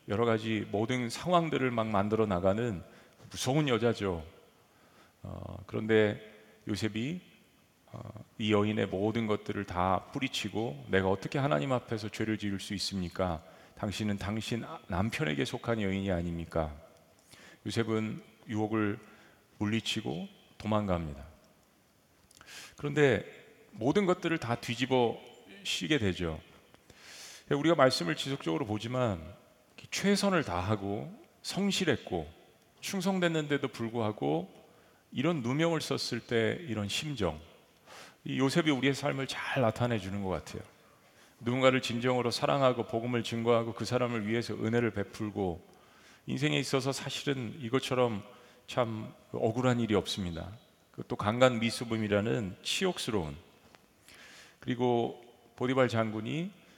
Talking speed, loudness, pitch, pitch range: 270 characters per minute, -32 LUFS, 115 Hz, 105-130 Hz